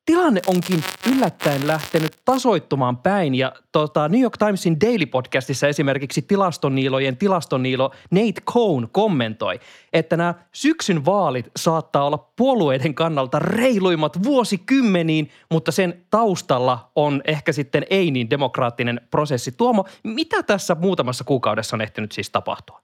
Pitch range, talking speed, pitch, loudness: 135-195 Hz, 125 wpm, 165 Hz, -20 LUFS